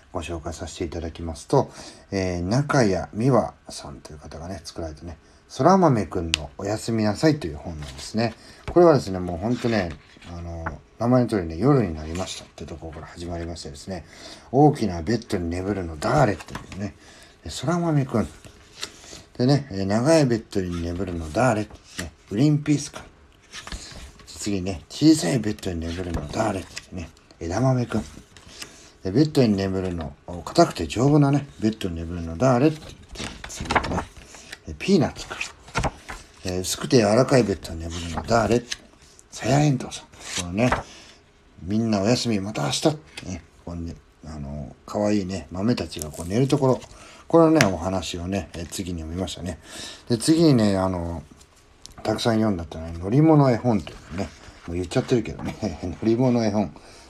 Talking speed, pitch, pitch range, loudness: 330 characters per minute, 95 Hz, 85-120 Hz, -23 LUFS